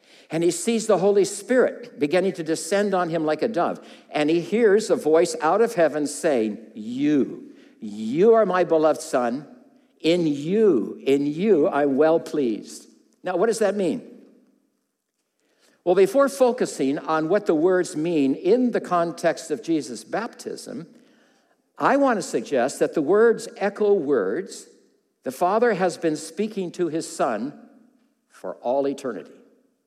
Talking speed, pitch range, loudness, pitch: 150 wpm, 160-245 Hz, -22 LUFS, 195 Hz